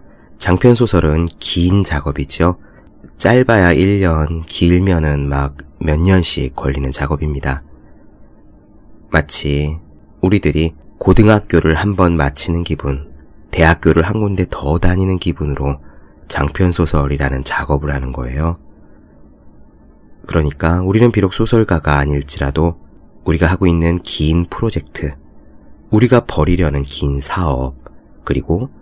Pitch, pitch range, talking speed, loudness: 80 Hz, 75-90 Hz, 250 characters per minute, -15 LUFS